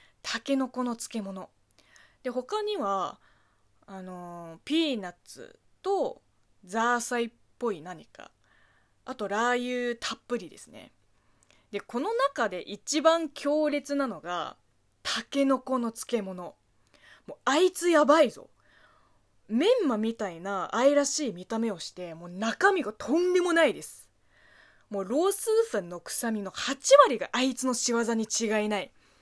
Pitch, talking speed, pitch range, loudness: 240 Hz, 255 characters per minute, 210-285 Hz, -28 LUFS